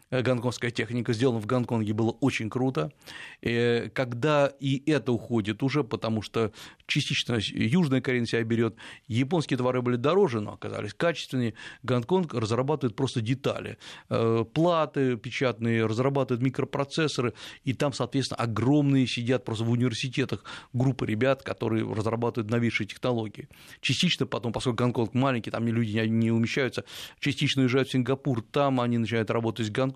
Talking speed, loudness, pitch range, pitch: 140 wpm, -27 LUFS, 115-135 Hz, 125 Hz